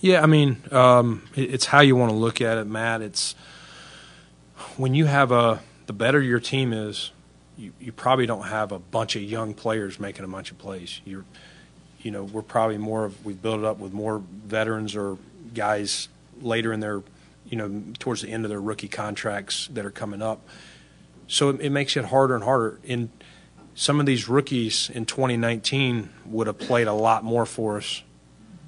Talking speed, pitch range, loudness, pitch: 195 wpm, 105-120 Hz, -23 LUFS, 110 Hz